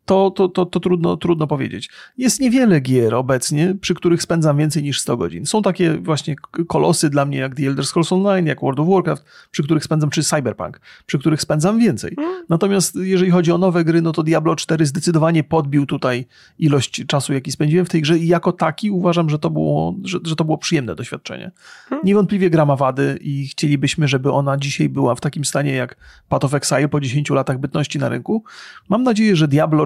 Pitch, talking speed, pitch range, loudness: 160 Hz, 205 wpm, 145-180 Hz, -18 LUFS